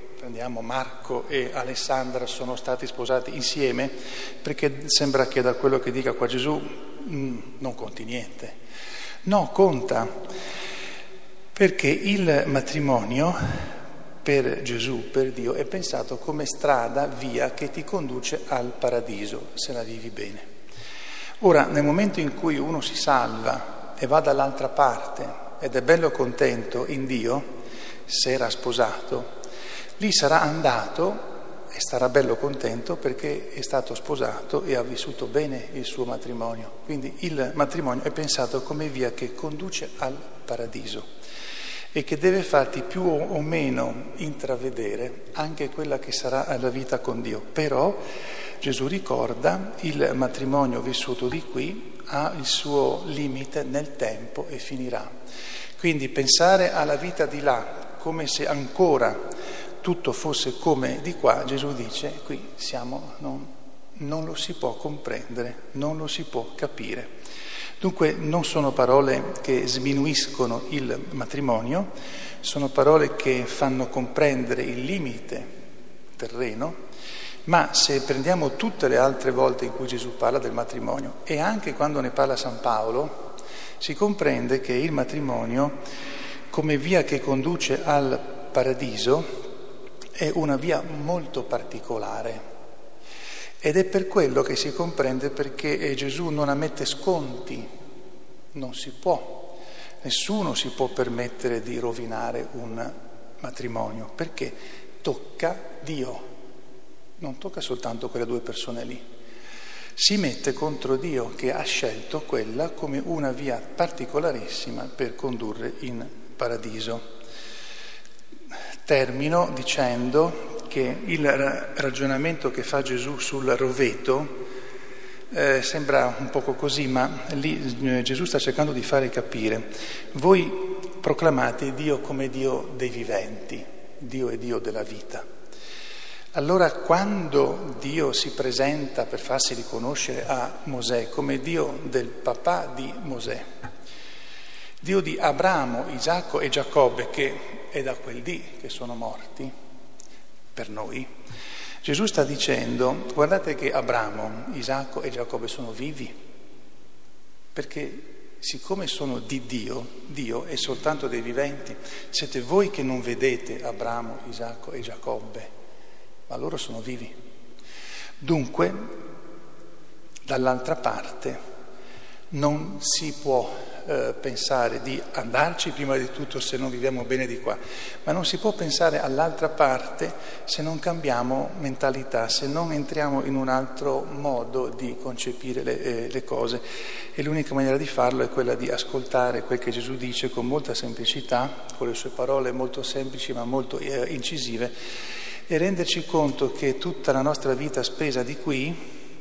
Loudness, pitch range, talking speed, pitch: -26 LUFS, 125-155 Hz, 130 wpm, 135 Hz